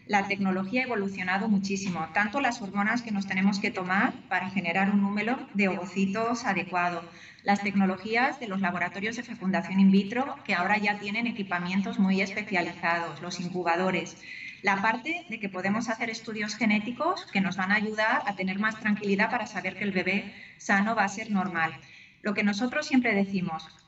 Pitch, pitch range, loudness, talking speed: 200 Hz, 185-220 Hz, -28 LUFS, 175 wpm